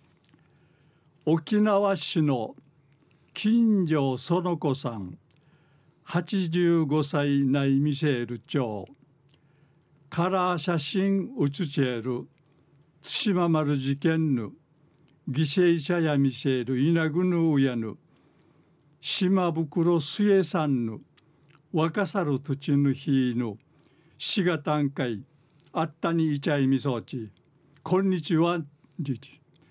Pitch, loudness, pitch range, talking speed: 150 Hz, -26 LUFS, 140-170 Hz, 170 characters per minute